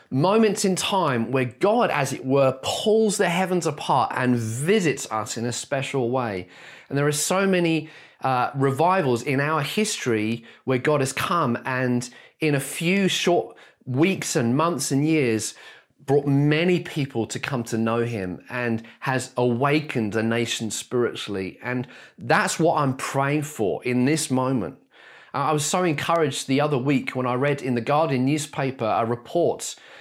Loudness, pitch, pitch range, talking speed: -23 LUFS, 135 Hz, 120-155 Hz, 165 wpm